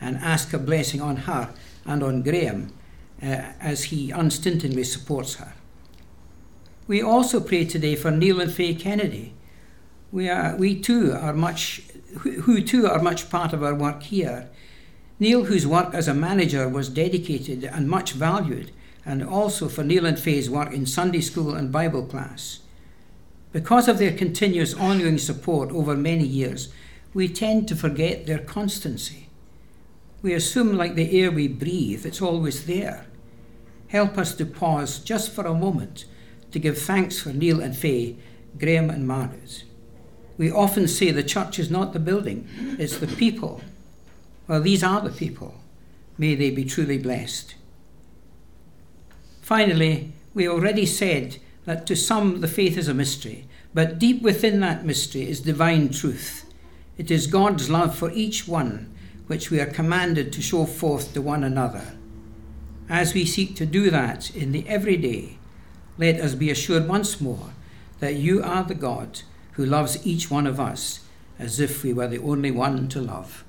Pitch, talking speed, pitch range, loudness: 155 Hz, 165 wpm, 130-180 Hz, -23 LUFS